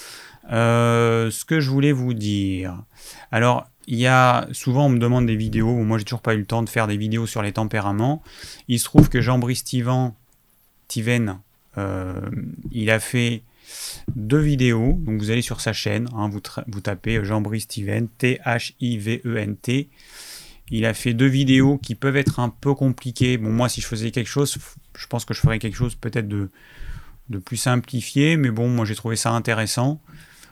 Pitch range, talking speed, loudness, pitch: 110-125 Hz, 190 wpm, -21 LUFS, 120 Hz